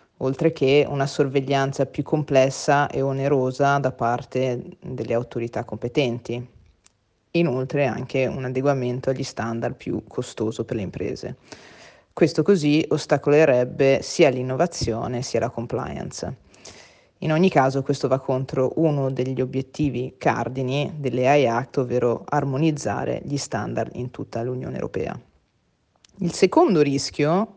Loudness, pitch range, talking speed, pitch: -23 LUFS, 125-145 Hz, 120 wpm, 135 Hz